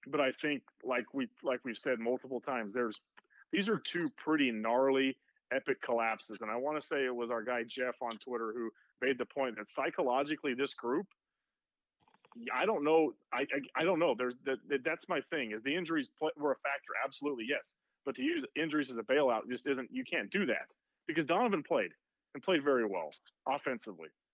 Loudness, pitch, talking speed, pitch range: -35 LUFS, 130 Hz, 200 wpm, 120-150 Hz